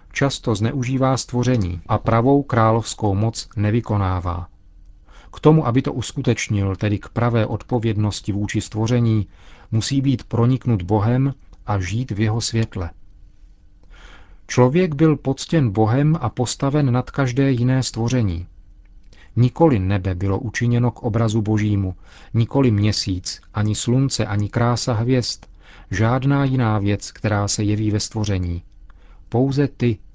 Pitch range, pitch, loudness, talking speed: 100-125 Hz, 110 Hz, -20 LUFS, 125 wpm